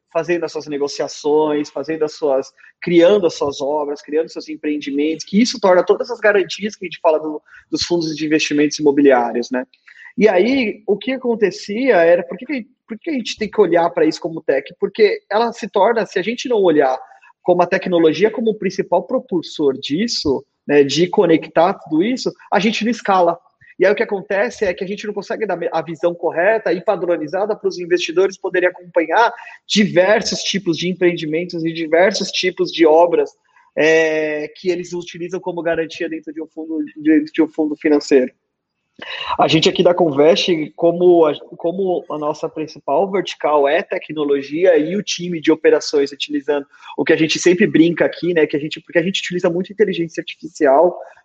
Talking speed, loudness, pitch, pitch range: 185 wpm, -17 LUFS, 175 Hz, 155-205 Hz